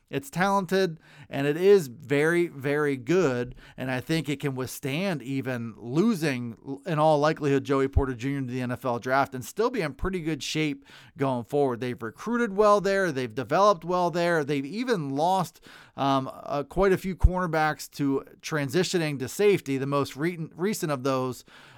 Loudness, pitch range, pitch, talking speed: -26 LUFS, 135-180 Hz, 145 Hz, 170 wpm